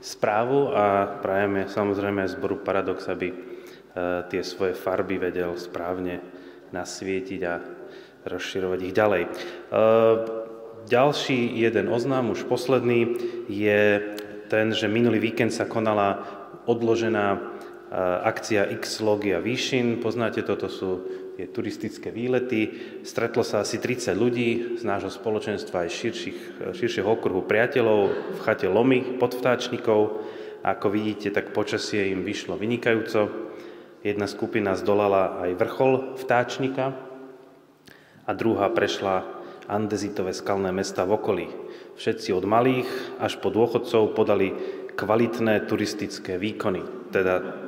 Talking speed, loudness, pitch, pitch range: 115 wpm, -25 LUFS, 110 Hz, 95-120 Hz